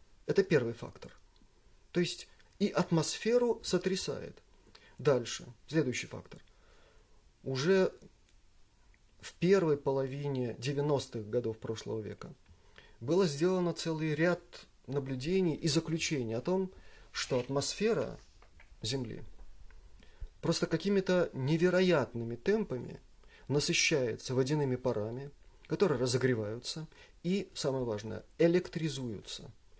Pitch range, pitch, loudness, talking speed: 115-170 Hz, 140 Hz, -33 LUFS, 90 wpm